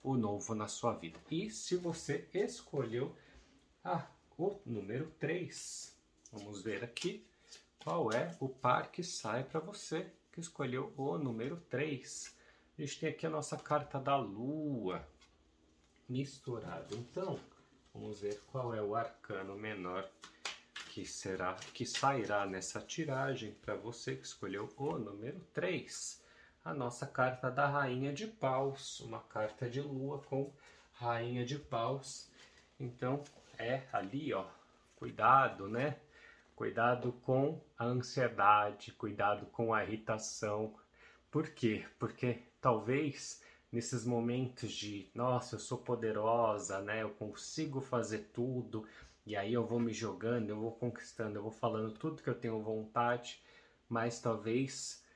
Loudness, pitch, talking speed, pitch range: -39 LUFS, 120 Hz, 135 wpm, 110-135 Hz